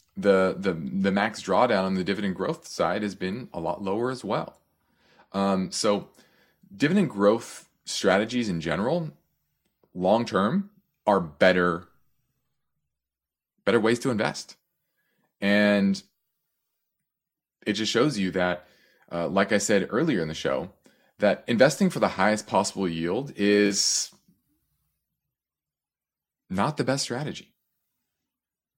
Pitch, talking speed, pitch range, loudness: 100 Hz, 120 wpm, 95-130 Hz, -25 LUFS